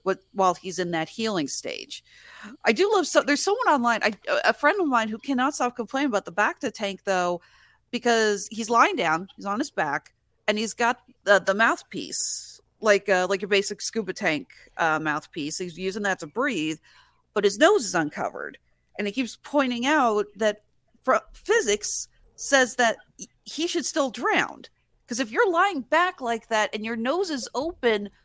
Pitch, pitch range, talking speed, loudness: 235 Hz, 200-295 Hz, 185 wpm, -24 LUFS